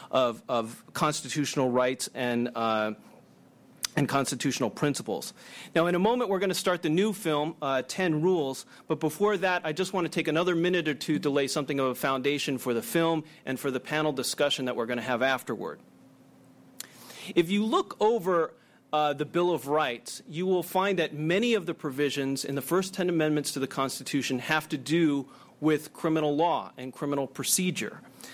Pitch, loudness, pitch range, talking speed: 150 Hz, -28 LUFS, 135-175 Hz, 190 wpm